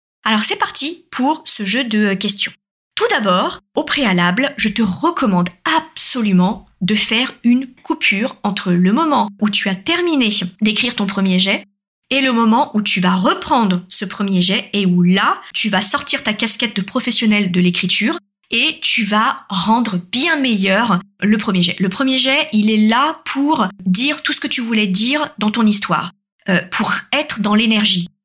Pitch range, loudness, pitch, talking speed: 195-260 Hz, -15 LUFS, 215 Hz, 175 wpm